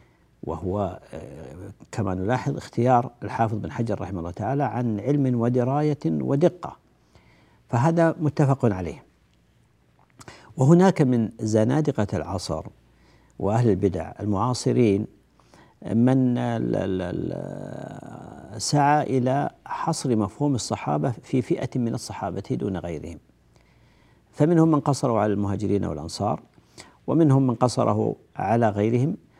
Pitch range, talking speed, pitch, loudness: 100-135 Hz, 95 wpm, 115 Hz, -24 LUFS